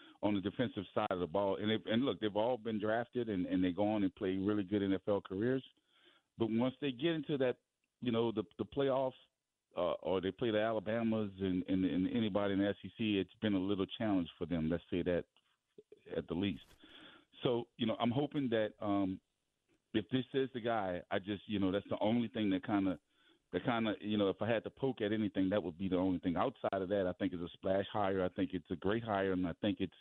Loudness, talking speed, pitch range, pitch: -37 LUFS, 245 wpm, 95-120 Hz, 105 Hz